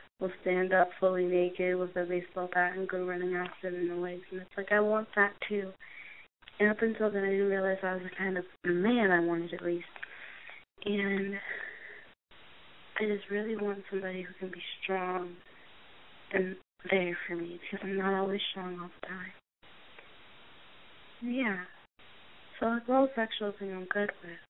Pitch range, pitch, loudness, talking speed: 180-200 Hz, 190 Hz, -32 LUFS, 175 wpm